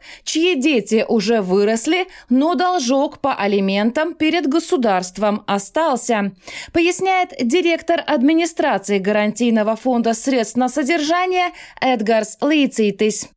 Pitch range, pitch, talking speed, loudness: 215-330 Hz, 260 Hz, 95 wpm, -17 LUFS